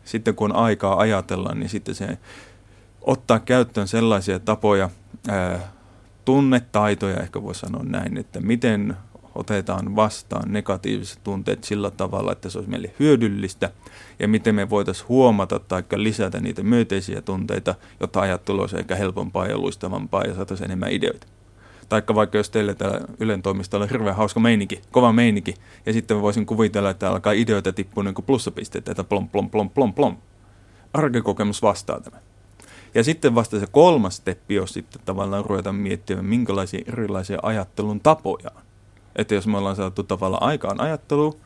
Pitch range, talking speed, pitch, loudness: 100-110 Hz, 155 wpm, 100 Hz, -22 LUFS